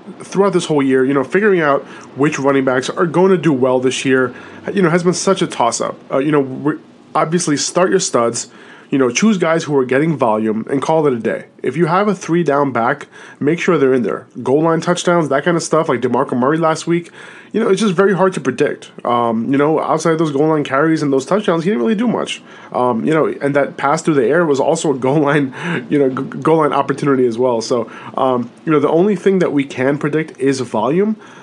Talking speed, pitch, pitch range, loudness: 245 wpm, 150 Hz, 135-175 Hz, -15 LUFS